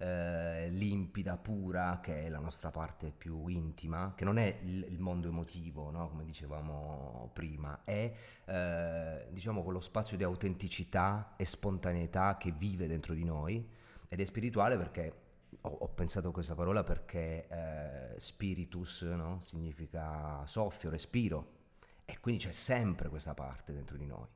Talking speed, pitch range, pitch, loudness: 145 wpm, 80-95 Hz, 85 Hz, -39 LUFS